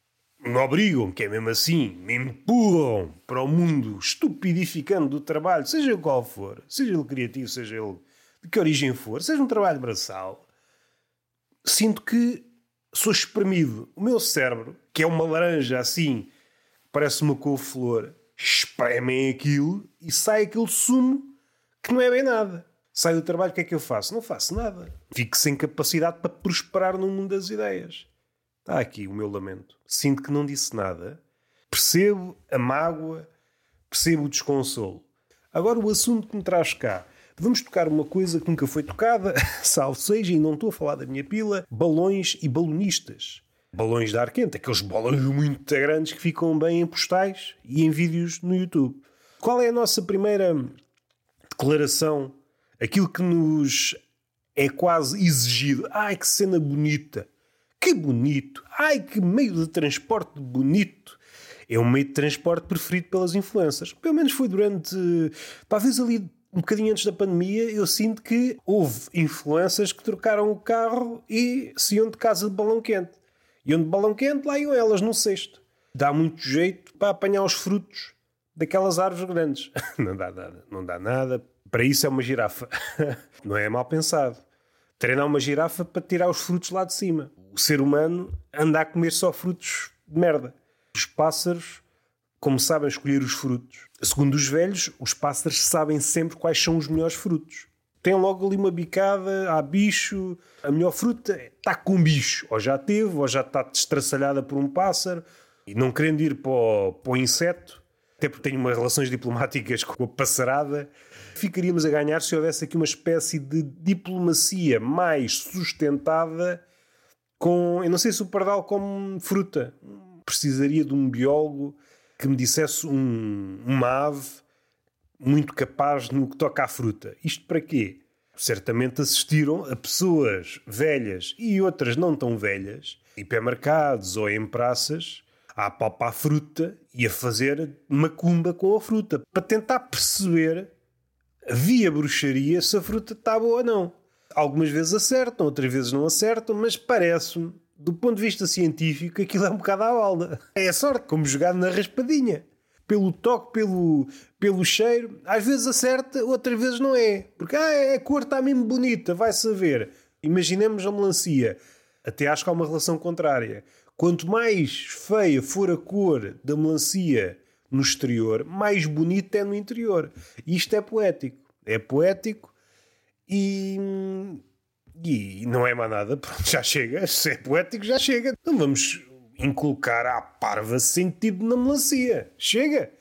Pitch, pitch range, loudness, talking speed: 165 Hz, 140-200 Hz, -24 LUFS, 160 wpm